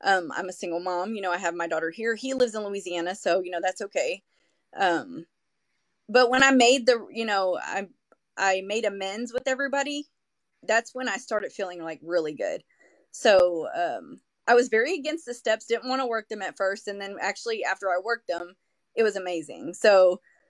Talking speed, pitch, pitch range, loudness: 200 wpm, 210 Hz, 185-250 Hz, -26 LUFS